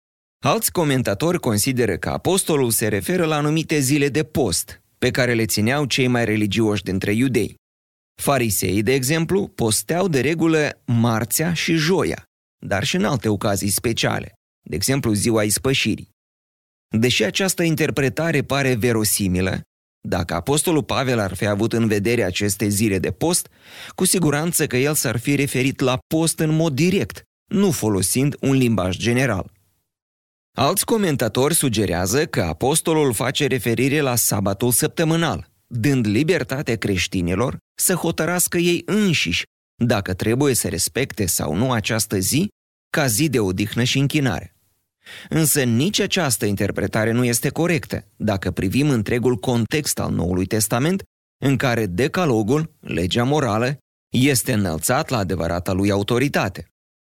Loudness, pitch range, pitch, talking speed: -20 LUFS, 105-150 Hz, 125 Hz, 135 wpm